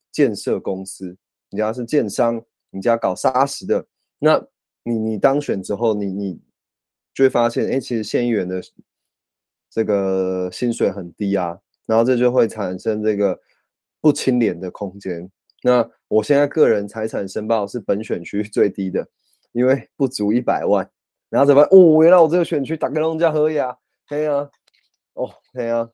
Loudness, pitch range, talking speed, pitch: -19 LUFS, 100-135 Hz, 250 characters per minute, 115 Hz